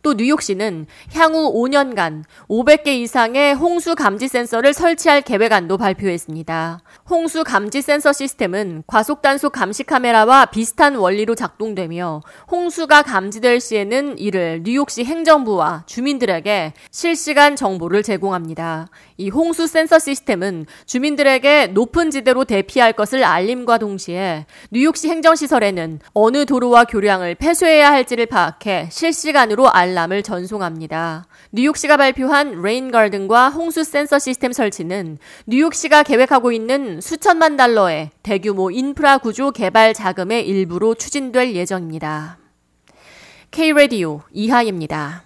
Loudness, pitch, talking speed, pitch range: -16 LUFS, 235 Hz, 320 characters per minute, 190-285 Hz